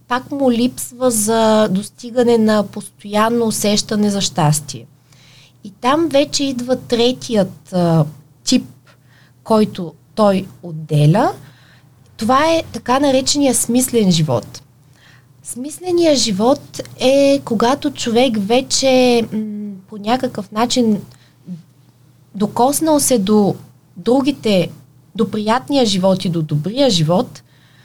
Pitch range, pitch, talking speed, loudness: 150-245 Hz, 210 Hz, 95 wpm, -16 LUFS